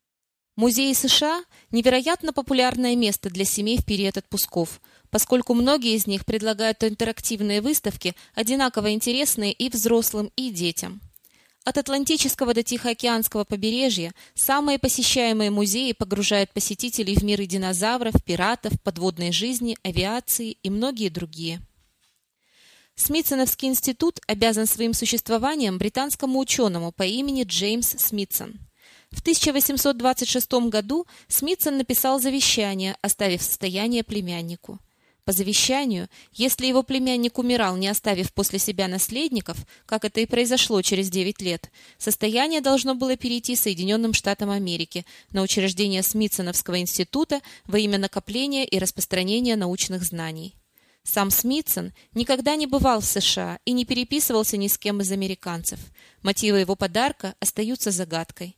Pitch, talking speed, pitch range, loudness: 220 Hz, 125 wpm, 195-255 Hz, -23 LUFS